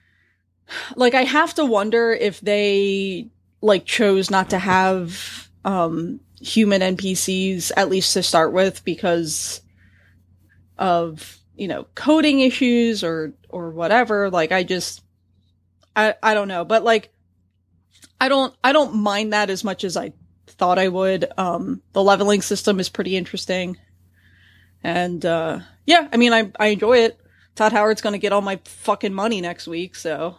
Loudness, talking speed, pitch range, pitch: -19 LUFS, 155 wpm, 165-210 Hz, 190 Hz